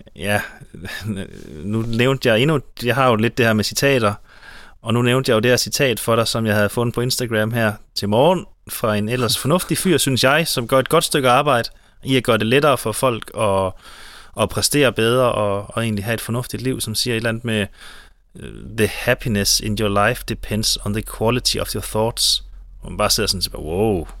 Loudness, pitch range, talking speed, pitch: -18 LUFS, 105-125 Hz, 215 wpm, 115 Hz